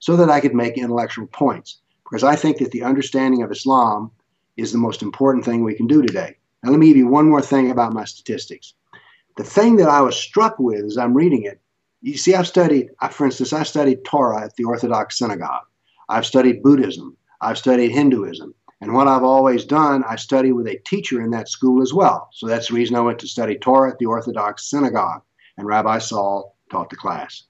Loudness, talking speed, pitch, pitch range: -17 LUFS, 215 wpm, 130 Hz, 115-145 Hz